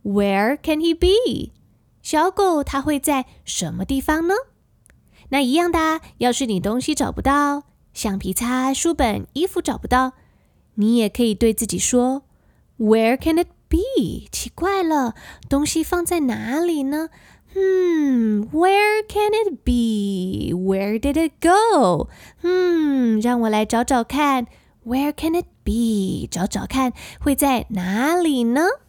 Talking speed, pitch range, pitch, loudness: 260 characters per minute, 230-325 Hz, 275 Hz, -20 LUFS